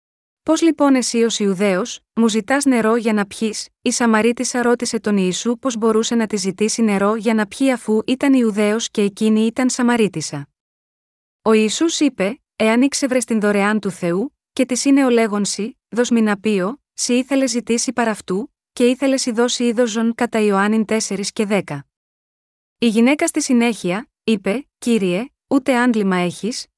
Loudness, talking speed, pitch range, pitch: -18 LUFS, 160 wpm, 210-250 Hz, 230 Hz